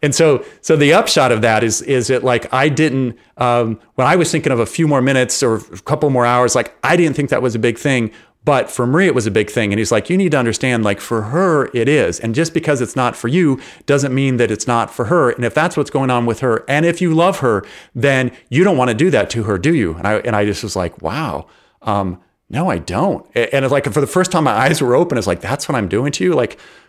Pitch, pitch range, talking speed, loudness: 130 Hz, 115-150 Hz, 285 wpm, -15 LUFS